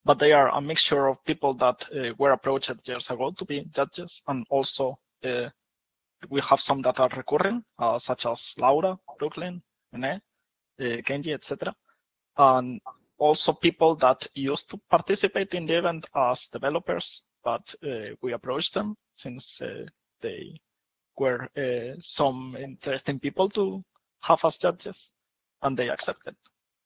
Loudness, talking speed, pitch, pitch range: -26 LUFS, 145 wpm, 140 Hz, 130-170 Hz